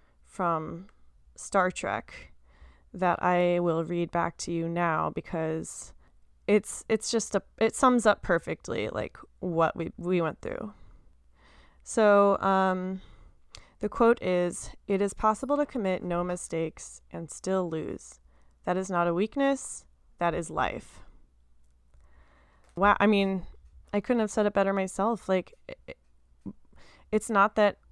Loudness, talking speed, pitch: -28 LUFS, 140 wpm, 175 Hz